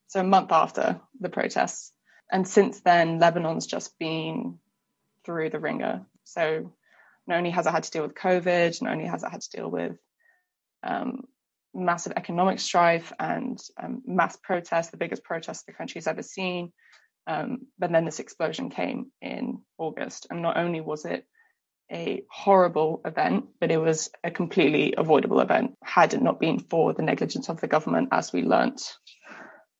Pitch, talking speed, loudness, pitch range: 175 Hz, 170 wpm, -26 LUFS, 165-205 Hz